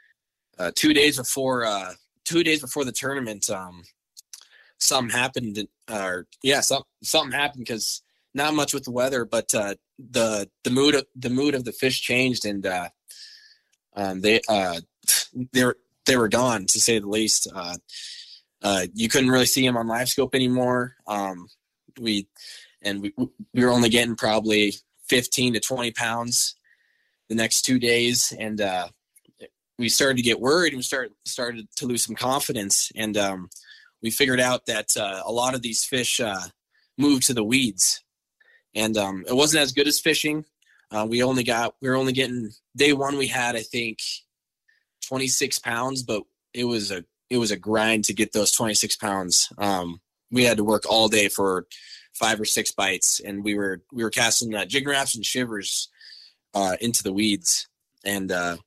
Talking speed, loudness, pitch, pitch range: 180 wpm, -22 LUFS, 120 Hz, 110-130 Hz